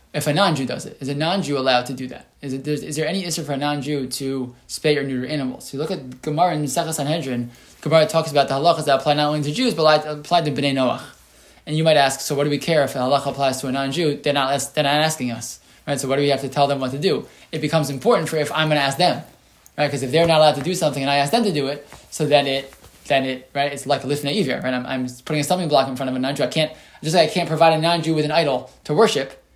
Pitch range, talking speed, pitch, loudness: 135-155 Hz, 300 wpm, 145 Hz, -20 LUFS